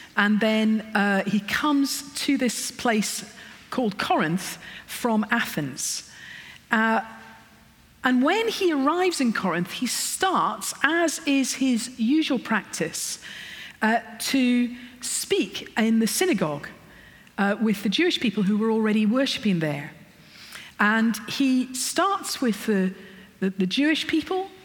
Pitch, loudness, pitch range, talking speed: 230 Hz, -24 LUFS, 210-275 Hz, 125 wpm